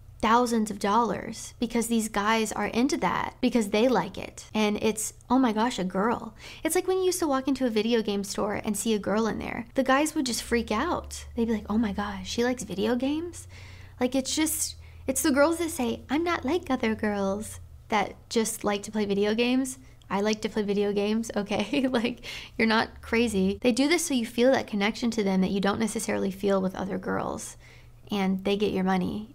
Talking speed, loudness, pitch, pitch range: 220 wpm, -27 LUFS, 225 Hz, 205-250 Hz